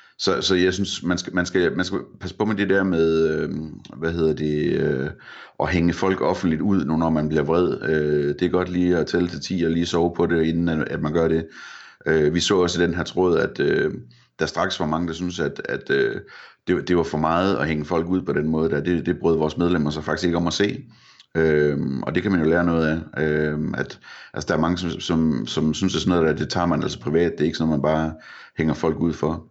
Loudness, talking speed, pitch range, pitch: -22 LUFS, 275 wpm, 80-90 Hz, 80 Hz